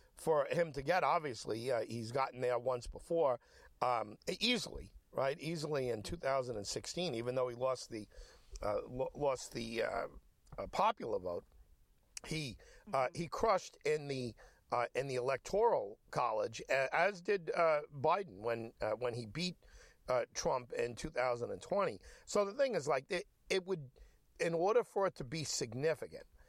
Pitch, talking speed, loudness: 160 Hz, 155 wpm, -37 LUFS